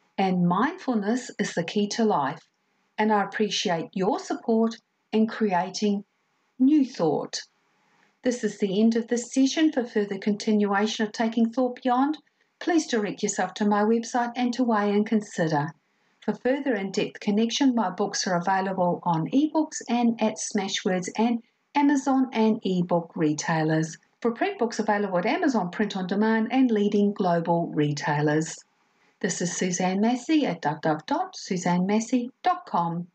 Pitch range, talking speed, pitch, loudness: 190-240 Hz, 145 wpm, 215 Hz, -25 LUFS